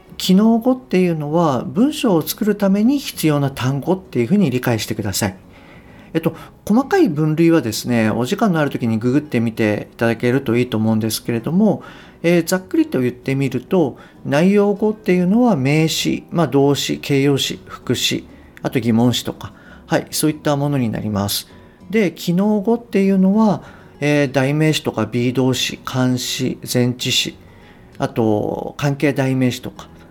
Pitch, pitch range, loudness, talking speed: 140 Hz, 120-185 Hz, -18 LUFS, 335 characters per minute